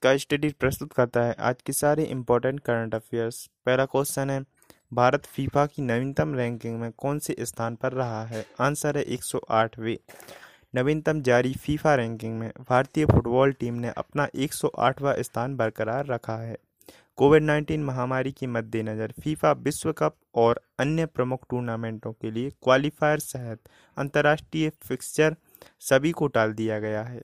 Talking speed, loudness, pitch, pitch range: 150 wpm, -26 LUFS, 130 Hz, 115-145 Hz